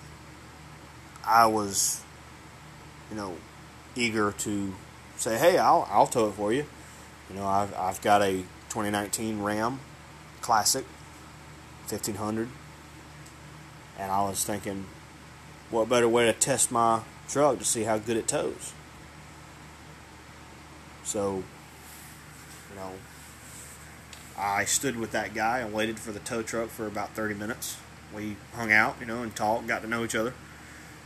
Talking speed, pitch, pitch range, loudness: 135 wpm, 105 Hz, 80-110 Hz, -27 LUFS